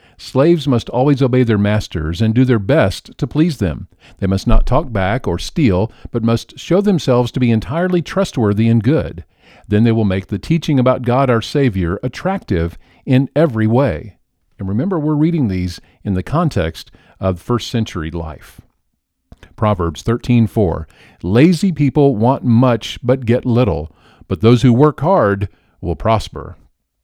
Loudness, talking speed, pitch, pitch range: -16 LUFS, 160 wpm, 115 Hz, 95-135 Hz